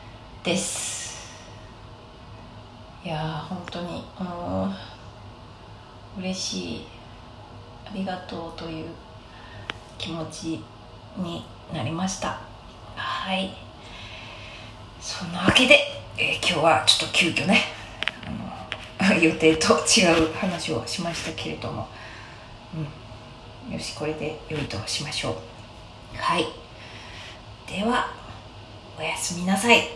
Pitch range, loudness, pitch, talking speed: 110-165 Hz, -24 LUFS, 120 Hz, 190 characters per minute